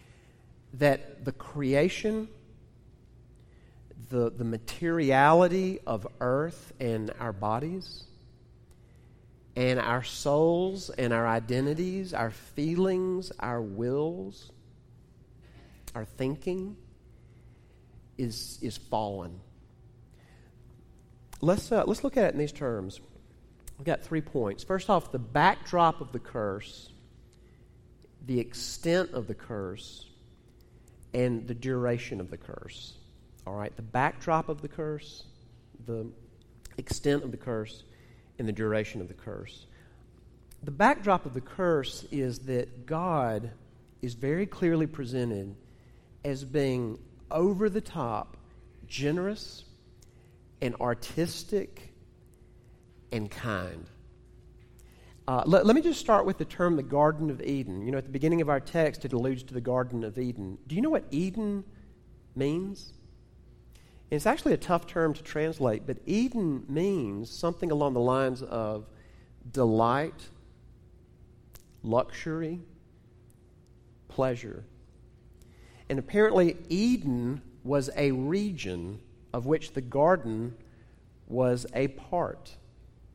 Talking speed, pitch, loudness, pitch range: 120 wpm, 125 Hz, -30 LUFS, 115-160 Hz